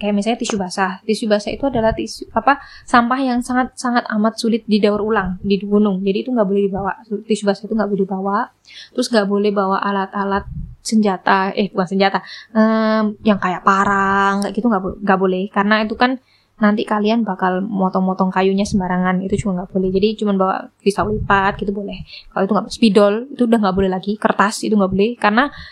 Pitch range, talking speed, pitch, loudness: 195-220 Hz, 185 wpm, 205 Hz, -17 LUFS